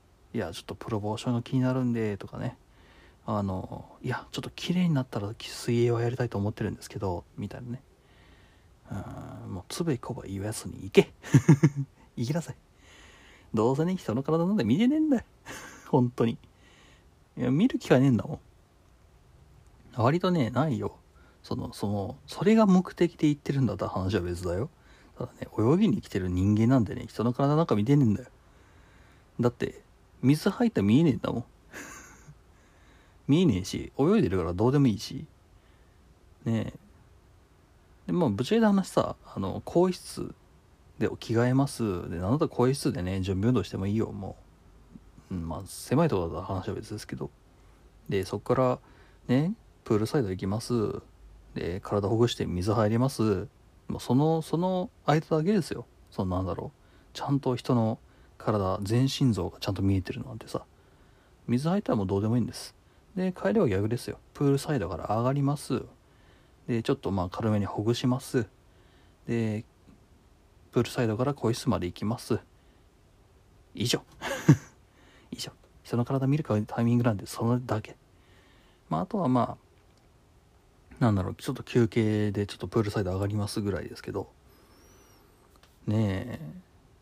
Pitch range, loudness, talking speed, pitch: 95-130 Hz, -28 LUFS, 320 characters per minute, 110 Hz